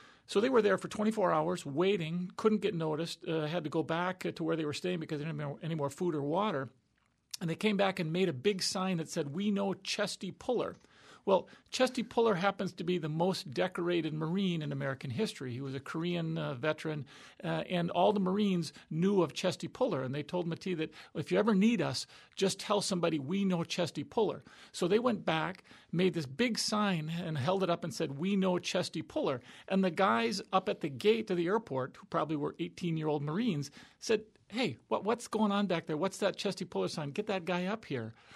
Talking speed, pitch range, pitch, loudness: 225 wpm, 160-200 Hz, 180 Hz, -33 LUFS